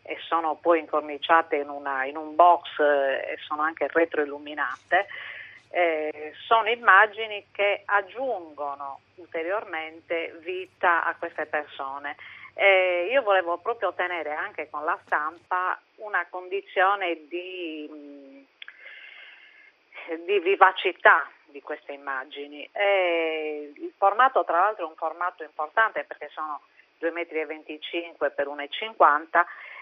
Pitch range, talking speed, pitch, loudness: 150-190 Hz, 110 wpm, 165 Hz, -25 LUFS